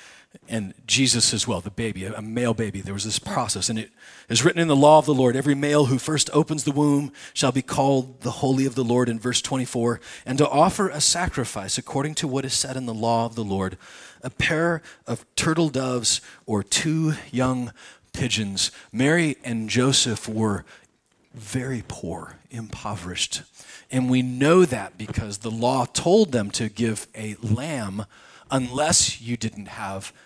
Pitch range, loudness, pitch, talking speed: 110-140 Hz, -23 LUFS, 125 Hz, 180 wpm